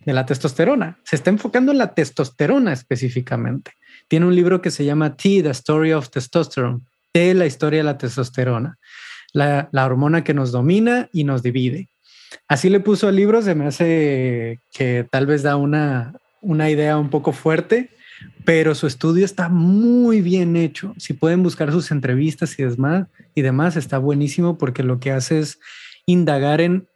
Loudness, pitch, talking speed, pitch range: -18 LUFS, 155 Hz, 170 wpm, 135-180 Hz